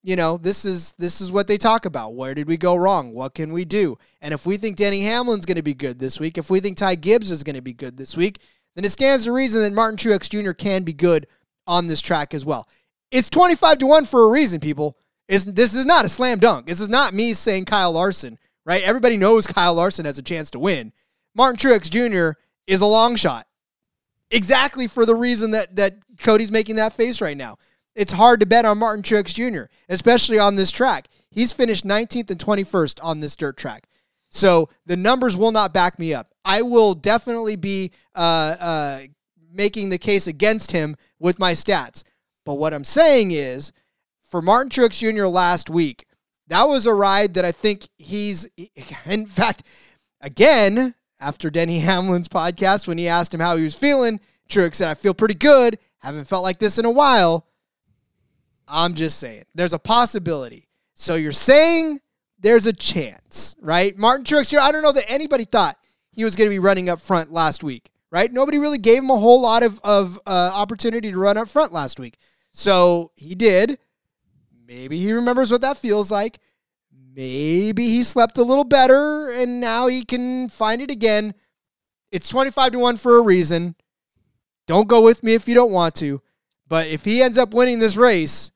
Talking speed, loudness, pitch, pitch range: 200 wpm, -18 LUFS, 200 Hz, 170-230 Hz